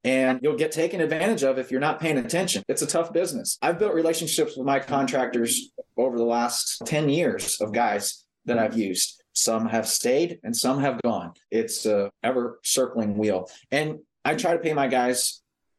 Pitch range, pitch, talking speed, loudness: 125-165 Hz, 140 Hz, 190 wpm, -24 LUFS